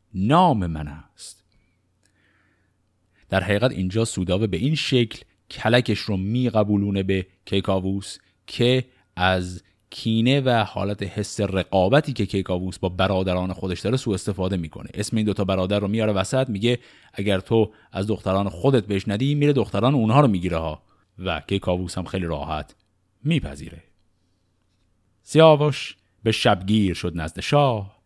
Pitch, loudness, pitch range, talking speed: 100 Hz, -22 LUFS, 95-110 Hz, 135 wpm